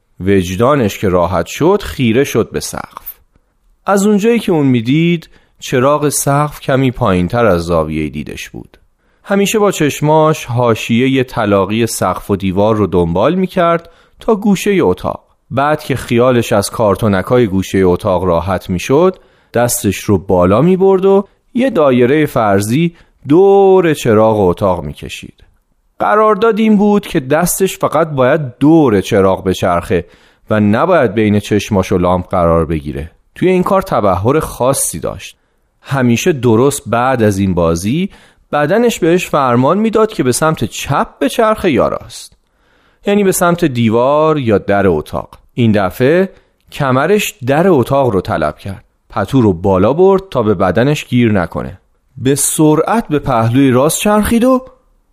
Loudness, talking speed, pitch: -12 LUFS, 150 wpm, 125 Hz